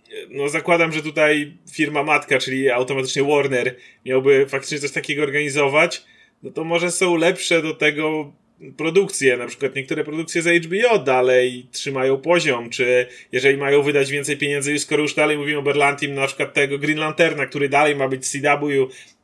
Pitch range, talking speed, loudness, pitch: 135-155 Hz, 170 wpm, -19 LUFS, 145 Hz